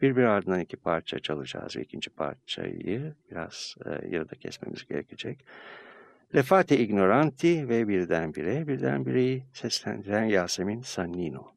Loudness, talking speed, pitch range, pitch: -28 LUFS, 120 wpm, 100-150 Hz, 120 Hz